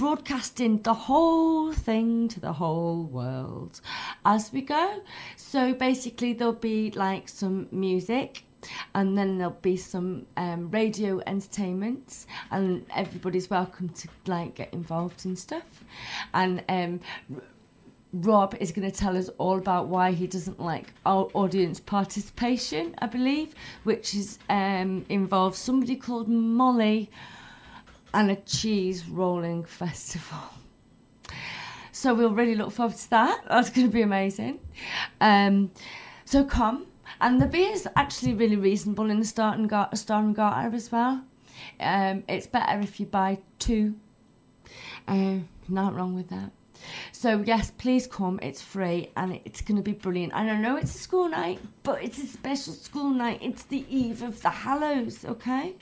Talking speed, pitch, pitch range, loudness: 155 wpm, 205 Hz, 185-240 Hz, -27 LUFS